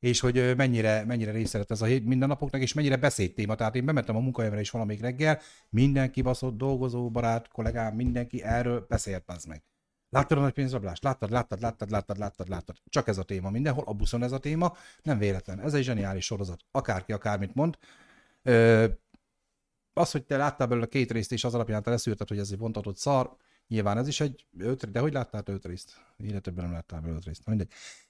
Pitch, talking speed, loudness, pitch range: 115 Hz, 205 wpm, -29 LUFS, 105-130 Hz